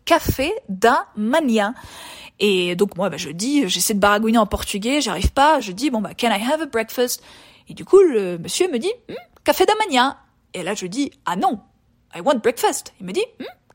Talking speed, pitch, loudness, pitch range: 205 wpm, 235 Hz, -19 LUFS, 205-300 Hz